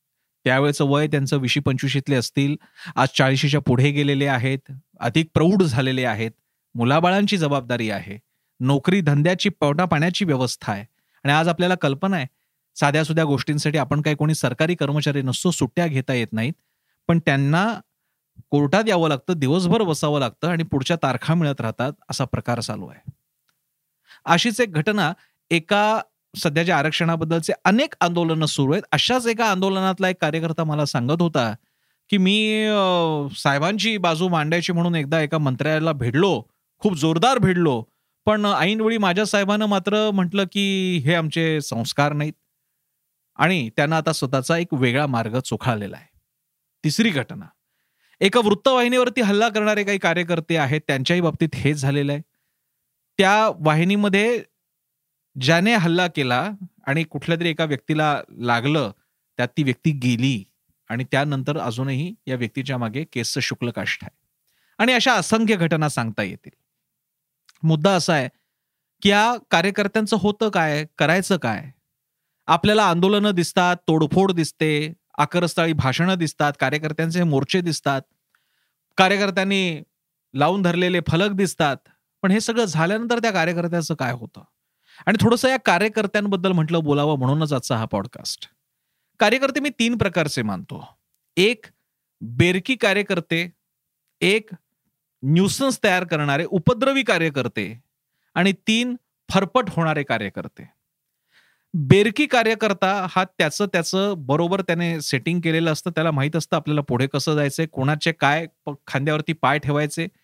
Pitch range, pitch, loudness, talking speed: 140-190 Hz, 160 Hz, -21 LUFS, 130 wpm